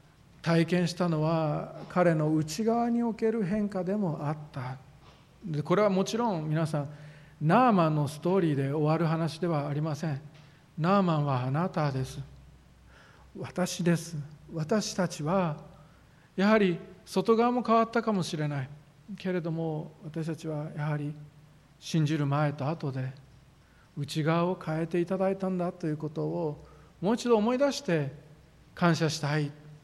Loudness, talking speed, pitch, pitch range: -29 LUFS, 275 characters per minute, 160 Hz, 150-185 Hz